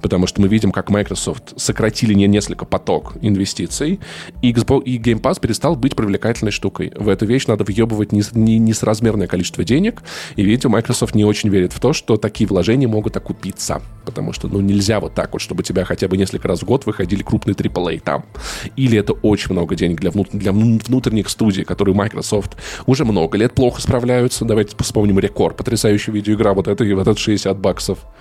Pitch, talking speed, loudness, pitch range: 105 Hz, 190 wpm, -17 LUFS, 100-115 Hz